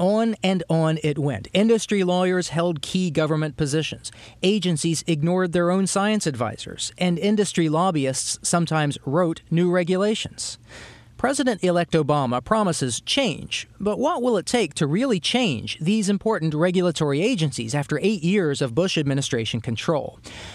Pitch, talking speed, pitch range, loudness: 170 Hz, 140 wpm, 145-195 Hz, -22 LUFS